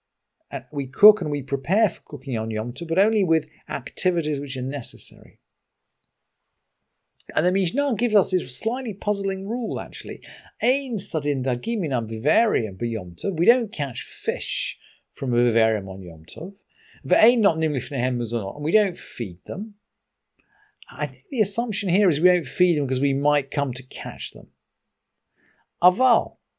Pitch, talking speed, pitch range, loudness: 155 Hz, 140 wpm, 125-205 Hz, -23 LUFS